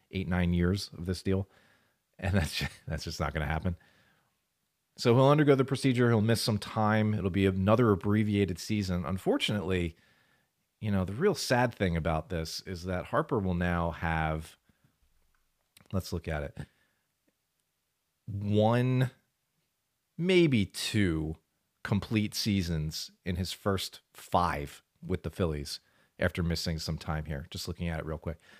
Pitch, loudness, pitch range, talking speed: 95 Hz, -30 LUFS, 85-110 Hz, 145 wpm